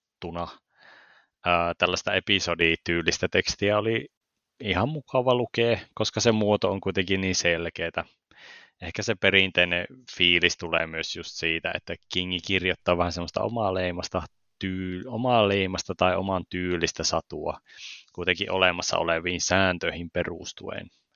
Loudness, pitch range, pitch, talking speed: -25 LUFS, 85-100 Hz, 90 Hz, 110 wpm